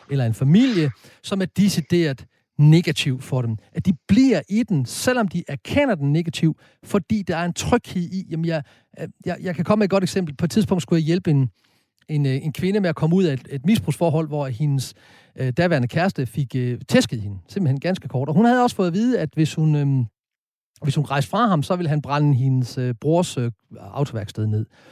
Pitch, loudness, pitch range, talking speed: 155 Hz, -21 LUFS, 135-185 Hz, 220 wpm